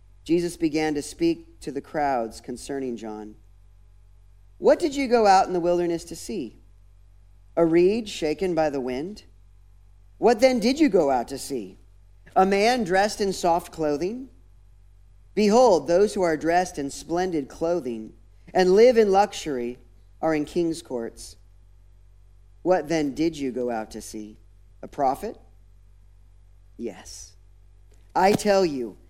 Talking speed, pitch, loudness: 140 wpm, 125 Hz, -23 LUFS